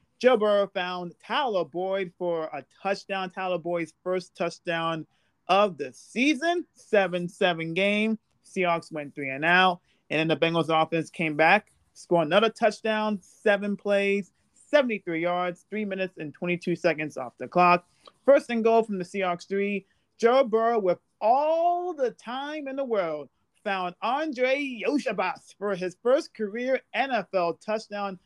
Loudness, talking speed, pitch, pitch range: -26 LUFS, 150 wpm, 190 Hz, 175-220 Hz